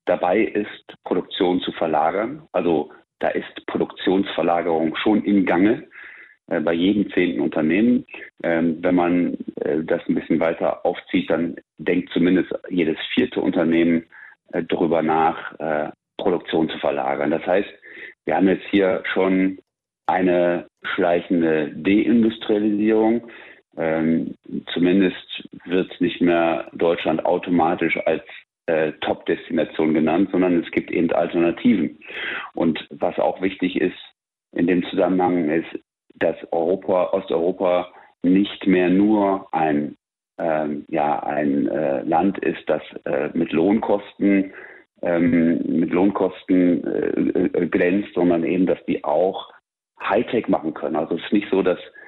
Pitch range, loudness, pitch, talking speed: 85-95 Hz, -21 LUFS, 90 Hz, 125 wpm